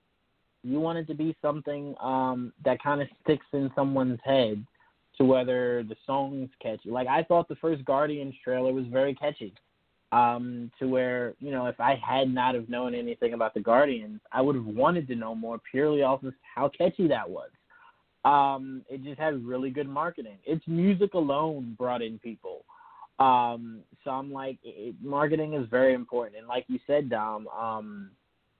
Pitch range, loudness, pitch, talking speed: 125-150 Hz, -28 LUFS, 130 Hz, 180 wpm